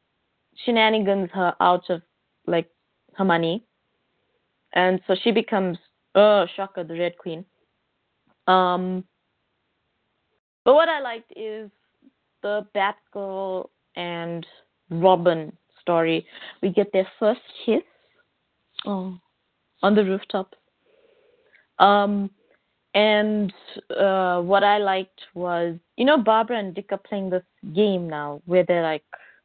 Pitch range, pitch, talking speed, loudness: 180-210 Hz, 195 Hz, 115 wpm, -22 LUFS